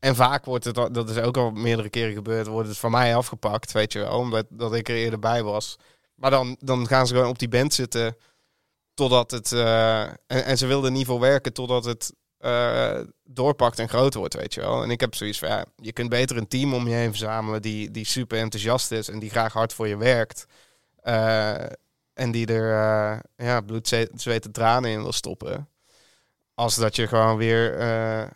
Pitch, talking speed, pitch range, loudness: 115 Hz, 210 wpm, 110-125 Hz, -24 LUFS